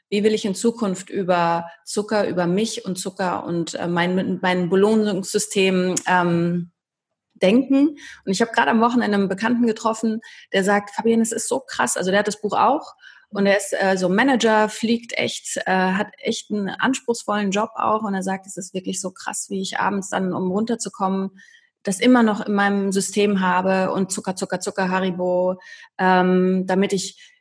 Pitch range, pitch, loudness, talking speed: 185-220 Hz, 195 Hz, -21 LUFS, 180 wpm